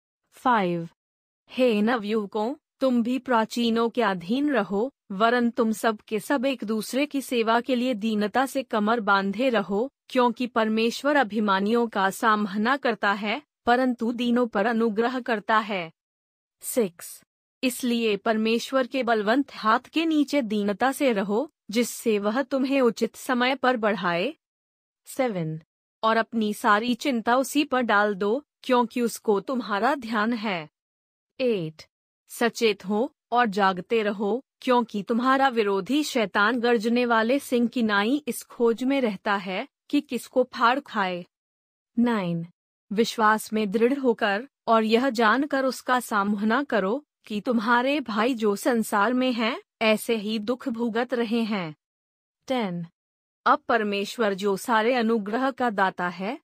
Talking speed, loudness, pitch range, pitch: 135 wpm, -24 LUFS, 210-255 Hz, 230 Hz